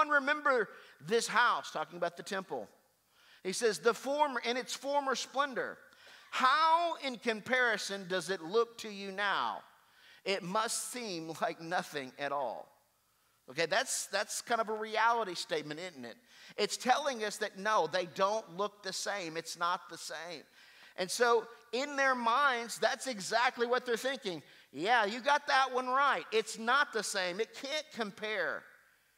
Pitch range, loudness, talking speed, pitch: 190-255 Hz, -33 LUFS, 160 wpm, 225 Hz